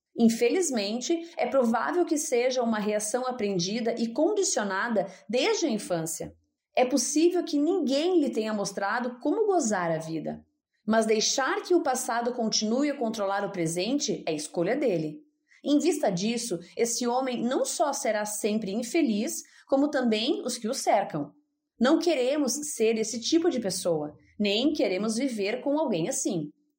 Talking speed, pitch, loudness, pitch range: 150 wpm, 240 Hz, -27 LUFS, 210-295 Hz